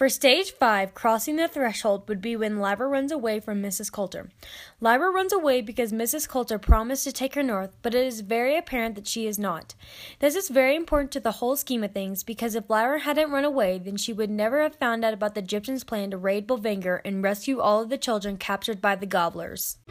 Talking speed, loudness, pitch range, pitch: 225 wpm, -25 LUFS, 205-270 Hz, 230 Hz